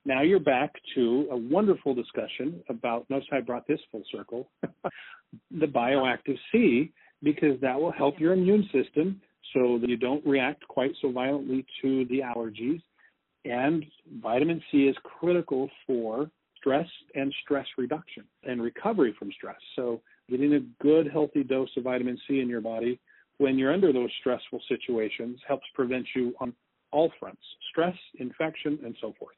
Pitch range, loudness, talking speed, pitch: 125-150 Hz, -28 LUFS, 160 wpm, 135 Hz